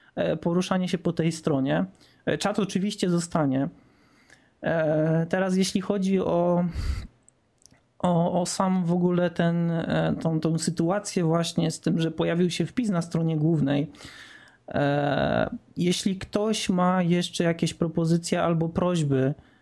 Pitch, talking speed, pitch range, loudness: 175 Hz, 120 wpm, 165-190 Hz, -25 LUFS